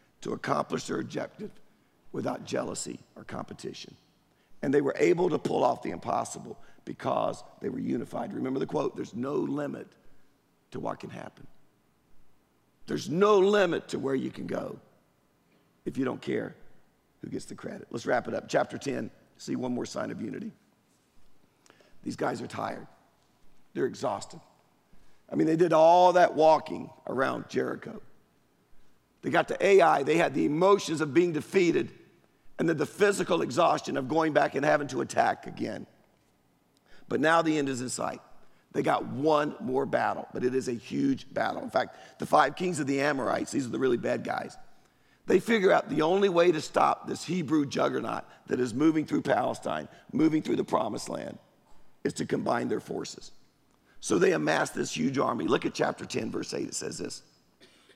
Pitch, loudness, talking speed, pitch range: 165 Hz, -28 LUFS, 175 wpm, 150-200 Hz